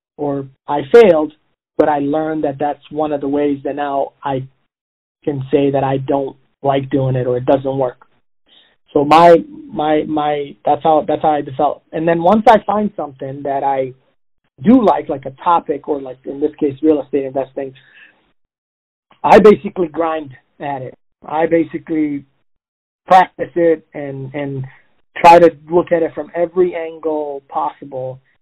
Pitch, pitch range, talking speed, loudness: 150 Hz, 140-160 Hz, 165 wpm, -15 LUFS